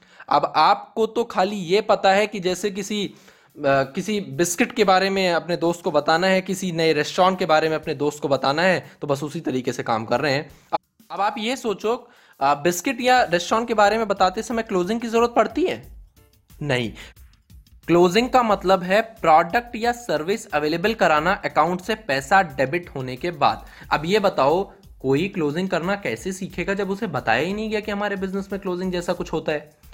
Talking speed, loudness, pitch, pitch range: 200 wpm, -21 LUFS, 185 Hz, 160-210 Hz